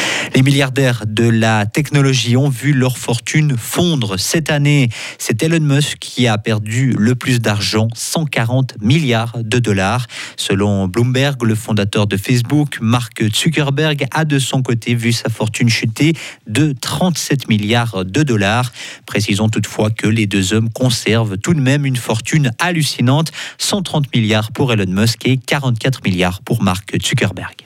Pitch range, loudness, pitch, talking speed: 110-140 Hz, -15 LUFS, 125 Hz, 150 wpm